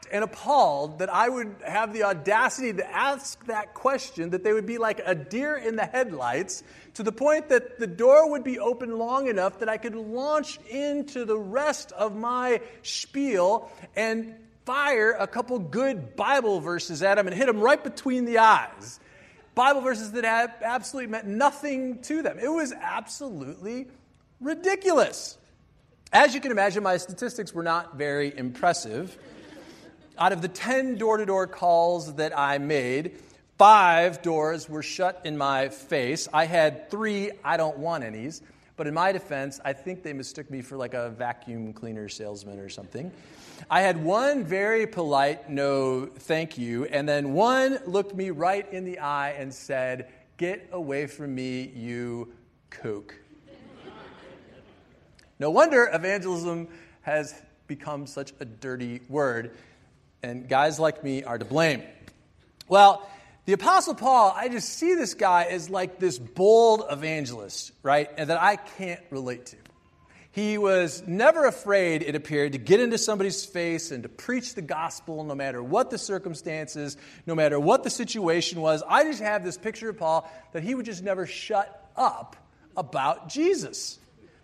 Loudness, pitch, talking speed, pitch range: -25 LUFS, 185 Hz, 160 wpm, 145-230 Hz